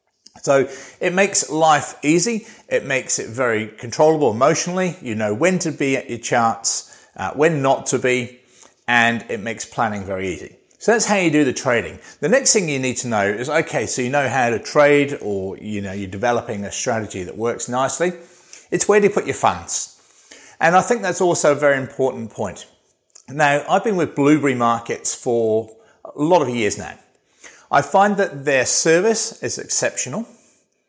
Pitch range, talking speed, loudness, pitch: 120-175 Hz, 190 wpm, -19 LUFS, 140 Hz